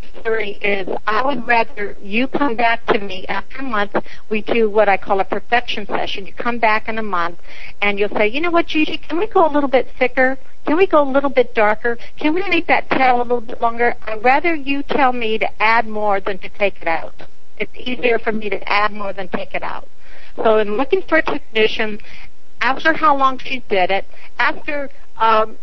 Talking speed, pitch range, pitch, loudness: 220 wpm, 205-270 Hz, 230 Hz, -18 LUFS